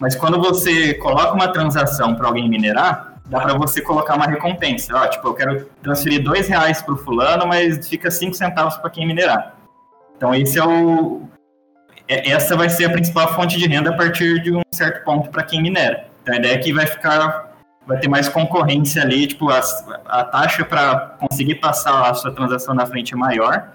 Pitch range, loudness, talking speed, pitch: 135-170 Hz, -17 LUFS, 200 wpm, 155 Hz